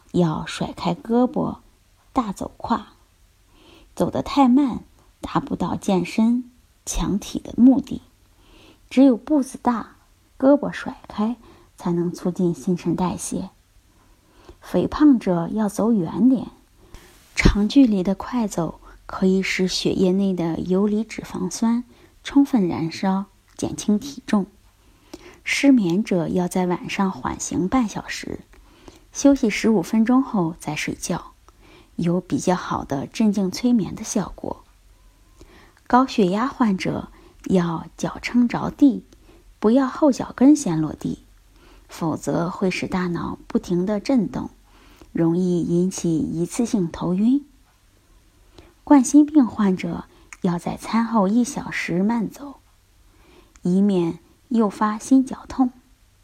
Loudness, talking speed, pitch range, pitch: -21 LUFS, 175 characters per minute, 180-255 Hz, 210 Hz